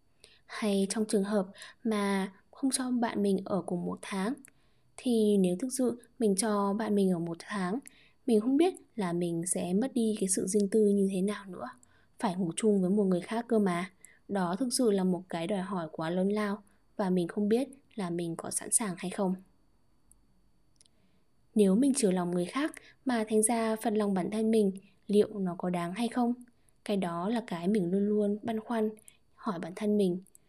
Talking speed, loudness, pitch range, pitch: 205 wpm, -31 LUFS, 190-225 Hz, 205 Hz